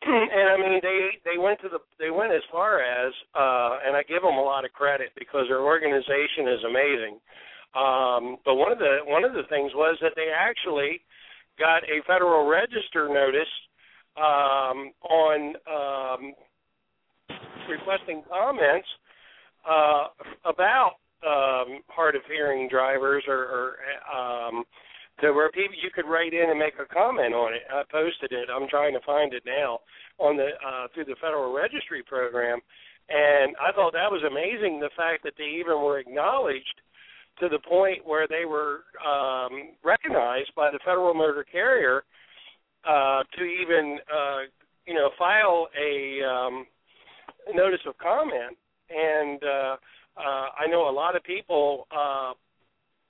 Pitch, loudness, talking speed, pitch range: 145 Hz, -25 LUFS, 155 wpm, 135-165 Hz